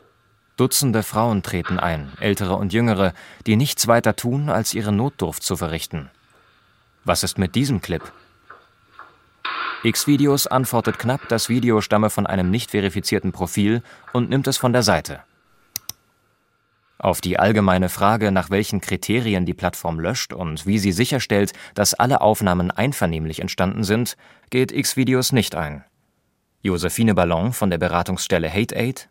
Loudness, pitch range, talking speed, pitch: -20 LUFS, 90-115 Hz, 140 wpm, 105 Hz